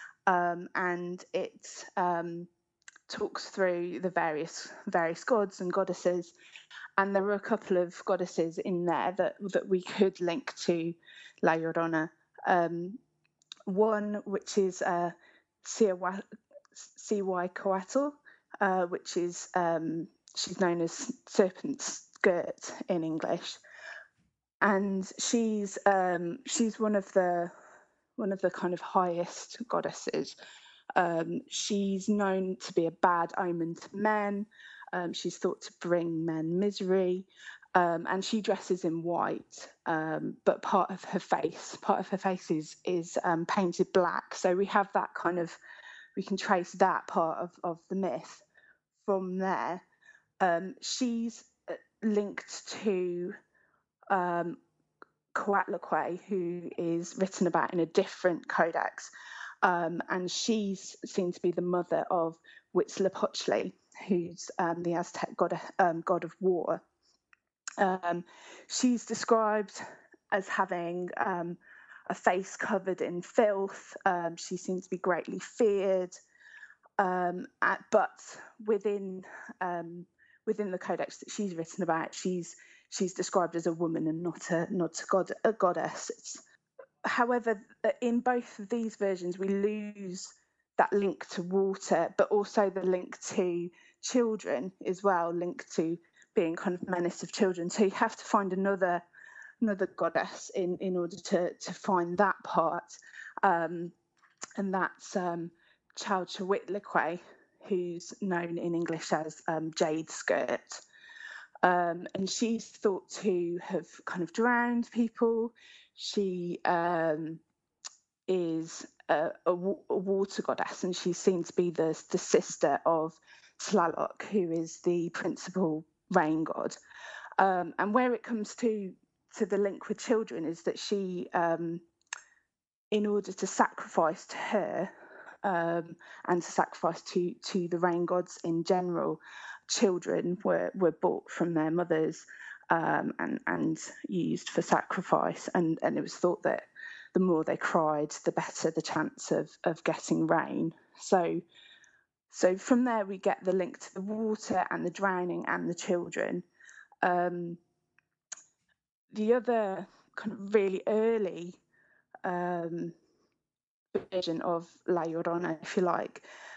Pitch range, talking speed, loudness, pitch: 175-205 Hz, 135 wpm, -31 LUFS, 185 Hz